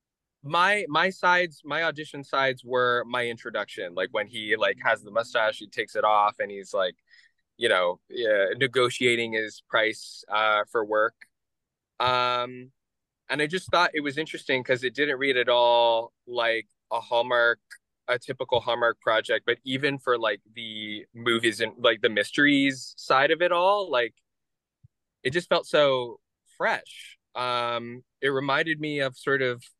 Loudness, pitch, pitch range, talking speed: -25 LUFS, 125 Hz, 120-150 Hz, 160 wpm